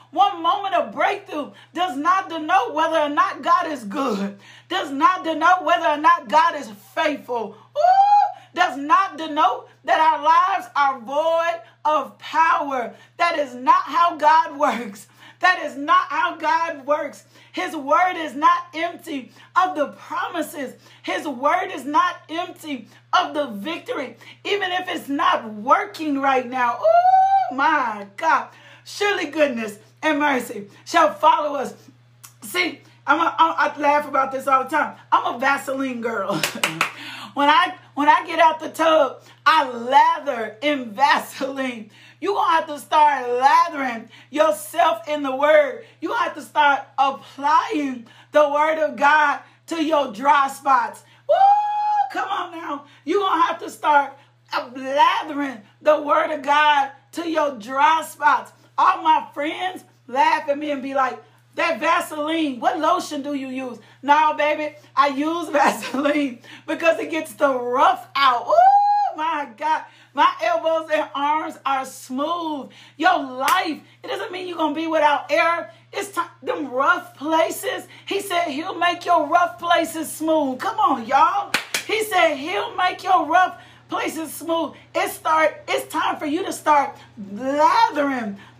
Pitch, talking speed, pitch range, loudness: 310 Hz, 150 wpm, 285-345 Hz, -20 LUFS